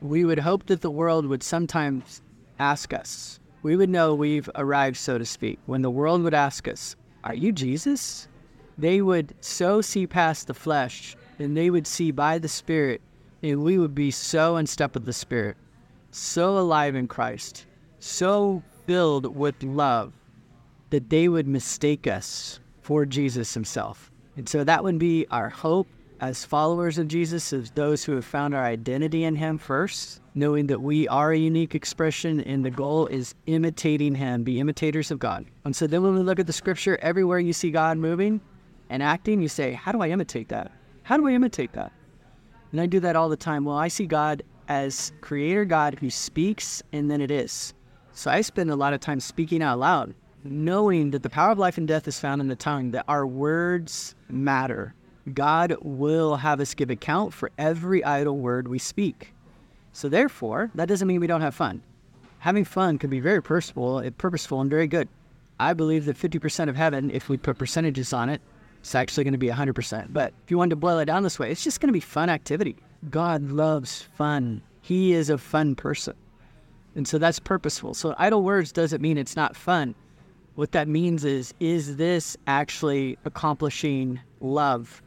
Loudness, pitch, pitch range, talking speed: -25 LUFS, 150 Hz, 140-170 Hz, 195 wpm